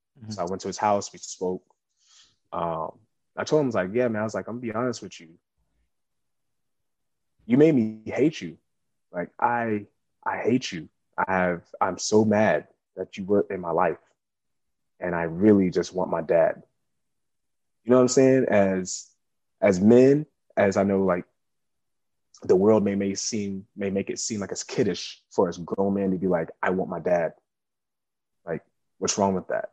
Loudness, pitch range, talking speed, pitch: -24 LUFS, 95-115 Hz, 190 wpm, 100 Hz